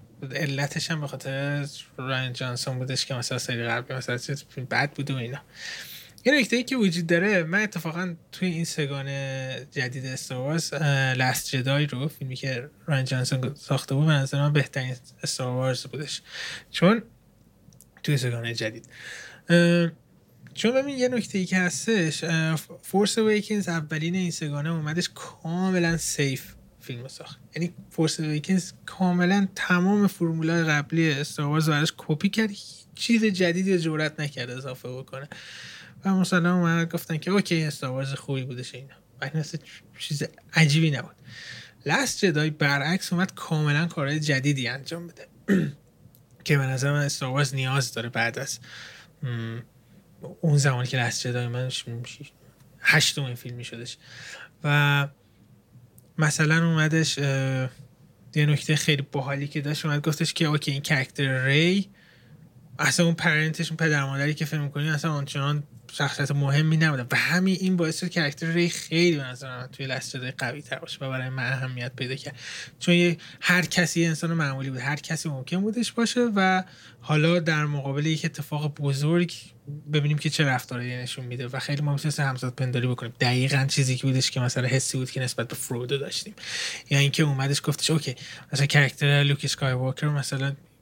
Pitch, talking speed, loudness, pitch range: 145 Hz, 150 wpm, -25 LUFS, 130-165 Hz